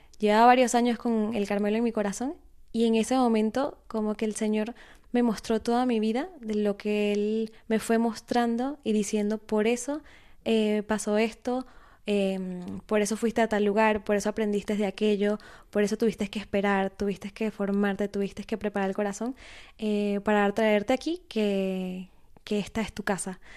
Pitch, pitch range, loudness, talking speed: 215 Hz, 205-230 Hz, -27 LUFS, 180 wpm